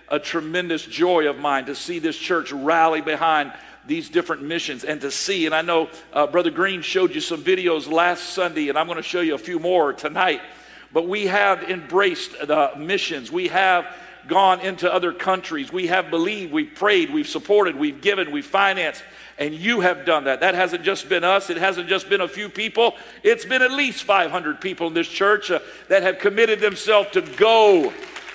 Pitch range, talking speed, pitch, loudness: 165-210 Hz, 200 wpm, 185 Hz, -20 LUFS